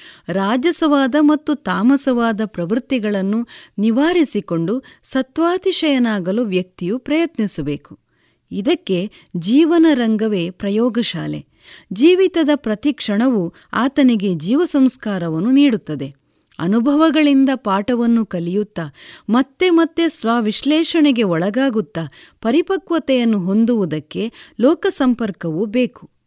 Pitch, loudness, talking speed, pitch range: 235 Hz, -17 LUFS, 65 wpm, 195-290 Hz